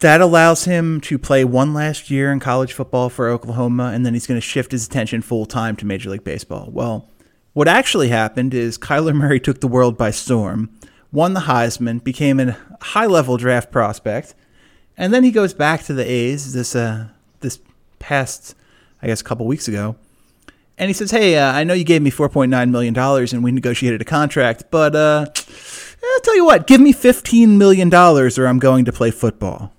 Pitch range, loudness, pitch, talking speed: 120-155 Hz, -15 LUFS, 130 Hz, 195 wpm